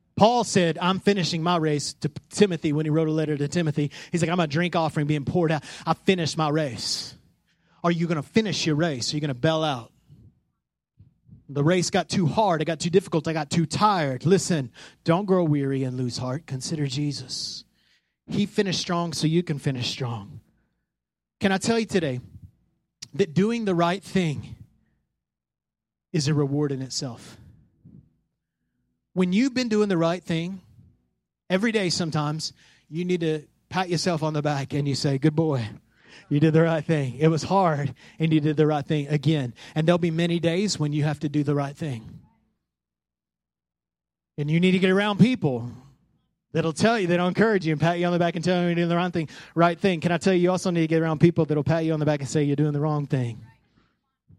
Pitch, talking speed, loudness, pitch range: 160 Hz, 210 wpm, -24 LUFS, 145-175 Hz